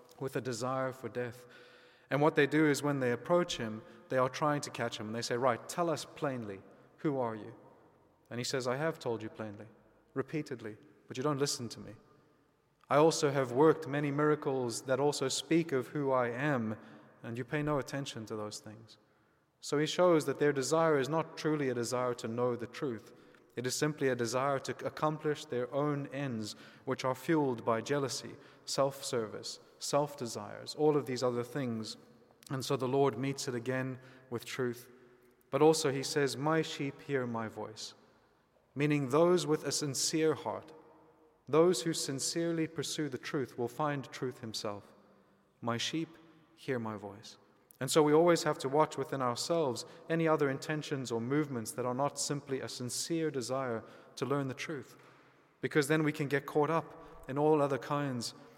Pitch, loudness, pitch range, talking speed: 135 Hz, -33 LUFS, 125-150 Hz, 180 wpm